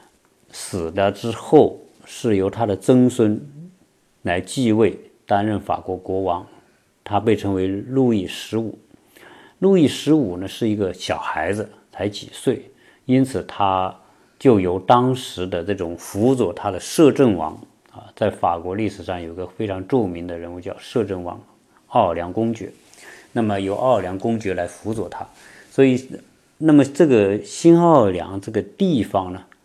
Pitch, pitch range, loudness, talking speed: 105 Hz, 95-125 Hz, -20 LUFS, 225 characters per minute